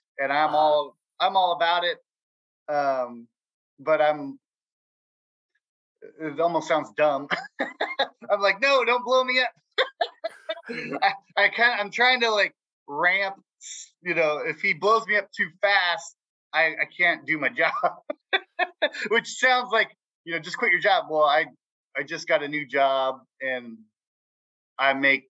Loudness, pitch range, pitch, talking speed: -23 LUFS, 150-230 Hz, 175 Hz, 150 wpm